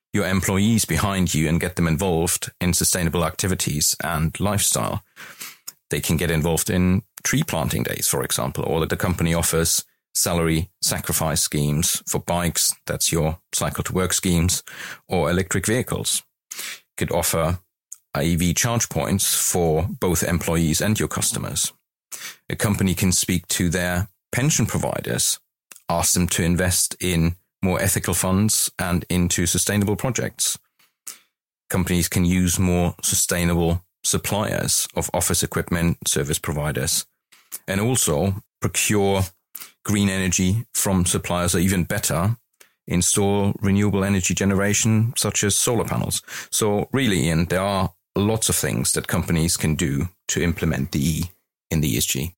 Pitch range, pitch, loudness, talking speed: 85-100 Hz, 90 Hz, -21 LUFS, 140 wpm